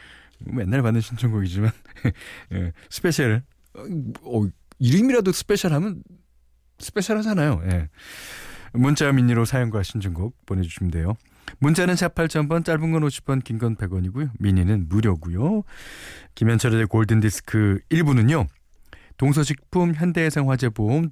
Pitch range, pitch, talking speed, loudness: 100-150 Hz, 115 Hz, 280 characters per minute, -22 LUFS